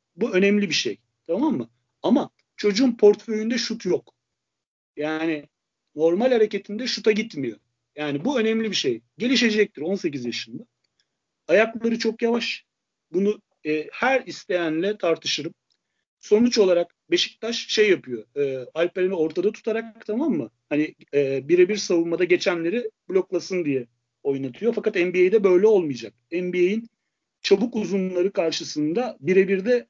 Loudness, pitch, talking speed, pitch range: -23 LUFS, 195 Hz, 120 wpm, 155-225 Hz